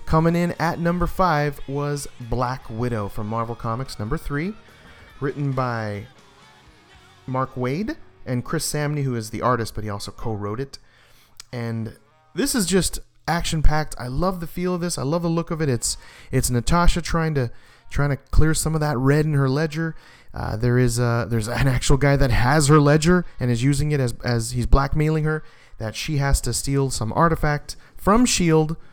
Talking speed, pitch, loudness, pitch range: 190 wpm, 140 Hz, -22 LUFS, 120-160 Hz